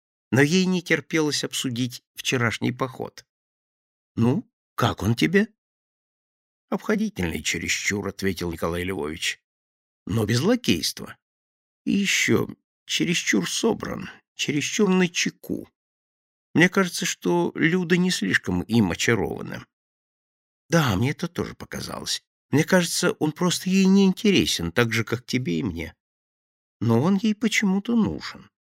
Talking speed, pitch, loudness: 120 wpm, 155 Hz, -23 LUFS